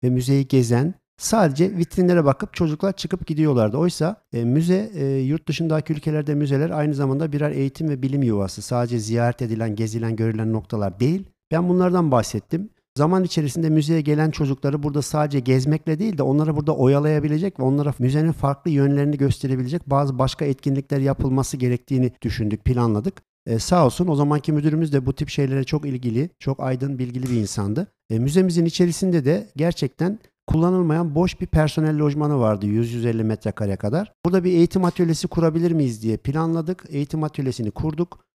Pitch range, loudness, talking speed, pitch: 130-165 Hz, -21 LUFS, 160 wpm, 145 Hz